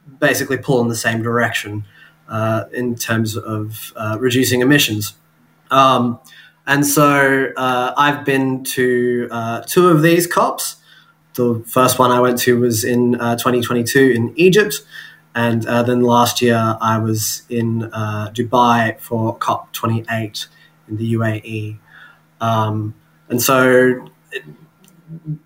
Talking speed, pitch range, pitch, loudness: 130 wpm, 115-130 Hz, 120 Hz, -16 LUFS